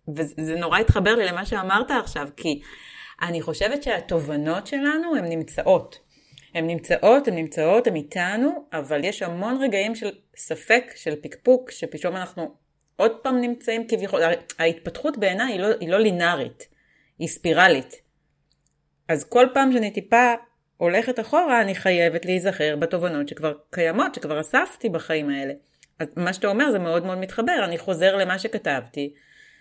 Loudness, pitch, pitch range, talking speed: -22 LUFS, 185 Hz, 165-230 Hz, 145 wpm